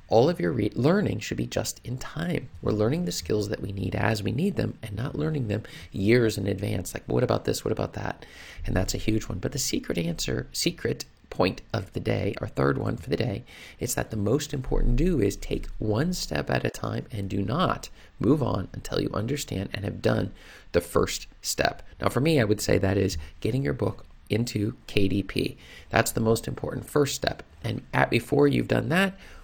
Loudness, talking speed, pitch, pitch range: -27 LUFS, 220 wpm, 105 Hz, 95-125 Hz